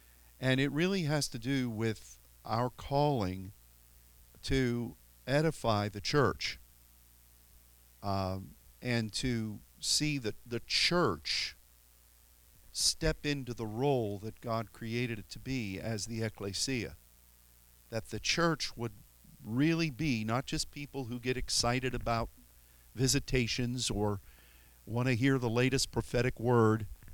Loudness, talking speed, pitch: -33 LUFS, 120 wpm, 115 Hz